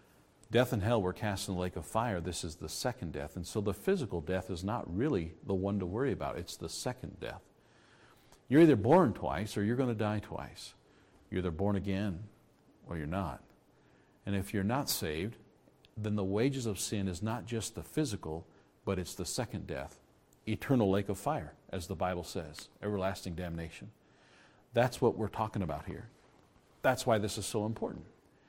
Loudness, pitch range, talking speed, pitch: -34 LUFS, 90-110 Hz, 190 wpm, 100 Hz